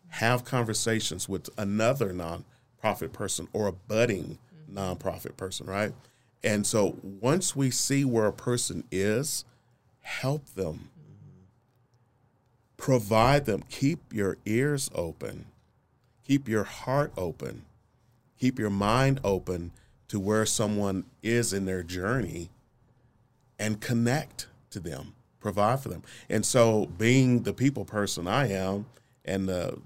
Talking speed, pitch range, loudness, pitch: 125 wpm, 100-125 Hz, -28 LUFS, 115 Hz